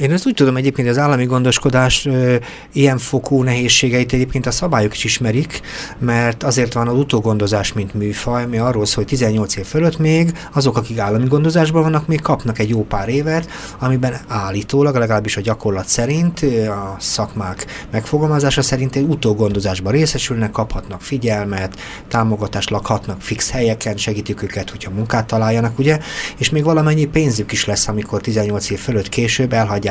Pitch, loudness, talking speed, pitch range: 120 Hz, -17 LUFS, 160 wpm, 105-140 Hz